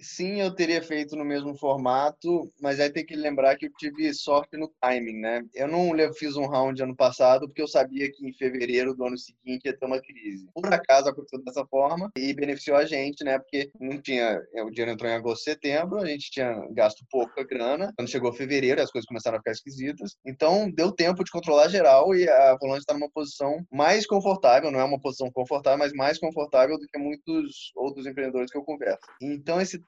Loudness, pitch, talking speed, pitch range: -25 LUFS, 145 Hz, 215 wpm, 130-155 Hz